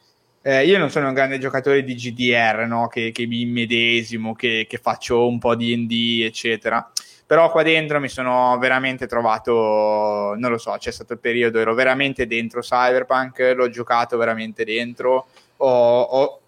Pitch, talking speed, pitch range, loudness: 120 Hz, 170 wpm, 115-130 Hz, -19 LUFS